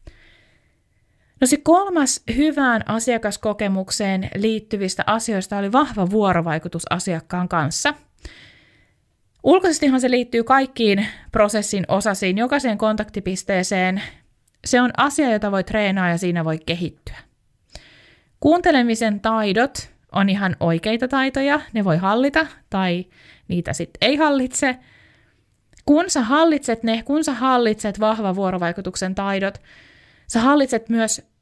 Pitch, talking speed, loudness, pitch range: 215 Hz, 105 wpm, -20 LUFS, 190-260 Hz